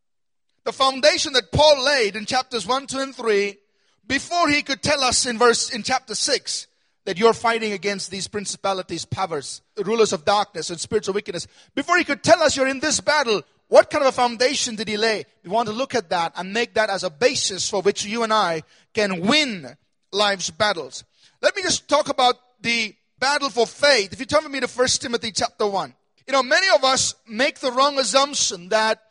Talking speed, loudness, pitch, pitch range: 210 wpm, -20 LUFS, 235 Hz, 205-270 Hz